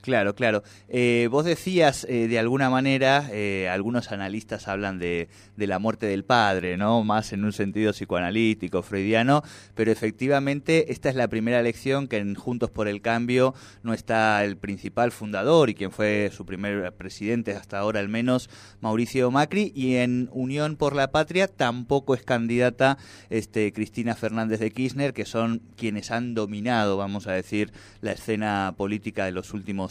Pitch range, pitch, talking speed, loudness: 100-125 Hz, 110 Hz, 170 wpm, -25 LUFS